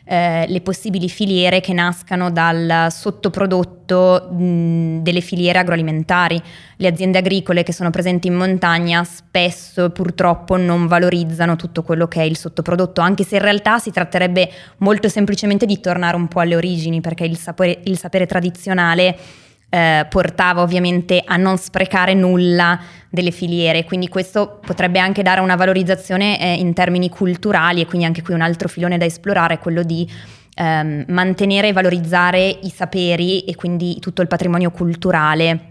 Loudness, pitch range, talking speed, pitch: -16 LUFS, 170-185 Hz, 160 wpm, 180 Hz